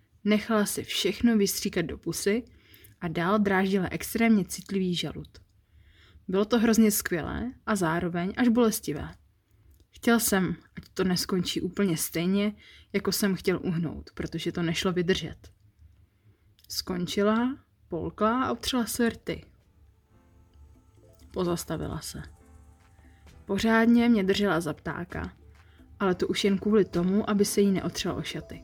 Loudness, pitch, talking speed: -27 LUFS, 175 Hz, 125 wpm